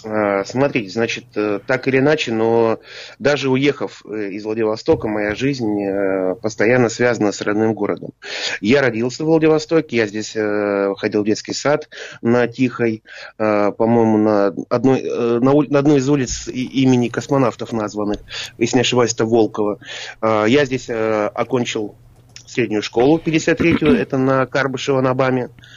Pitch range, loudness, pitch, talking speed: 110-130 Hz, -18 LUFS, 120 Hz, 125 wpm